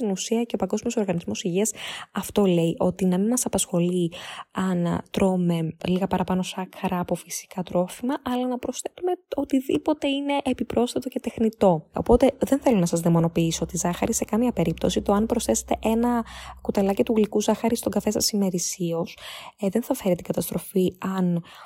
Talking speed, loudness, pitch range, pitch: 165 wpm, -24 LUFS, 180-240 Hz, 205 Hz